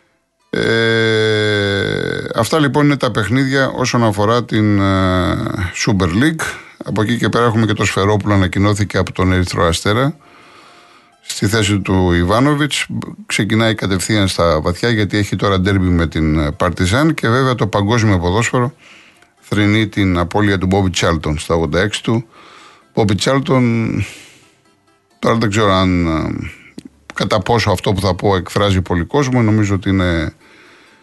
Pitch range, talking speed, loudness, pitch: 95-115 Hz, 140 wpm, -15 LUFS, 105 Hz